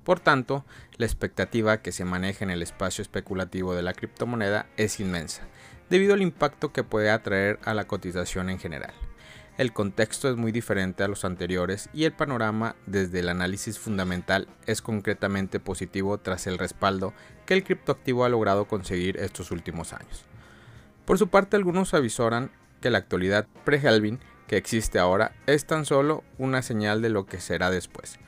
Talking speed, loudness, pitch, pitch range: 170 wpm, -26 LUFS, 105 Hz, 95-125 Hz